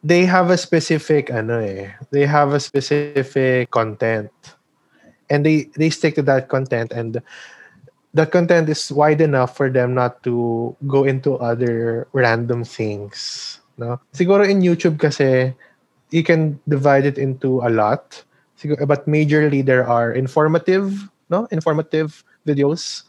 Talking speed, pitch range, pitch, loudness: 140 wpm, 125-155 Hz, 140 Hz, -18 LUFS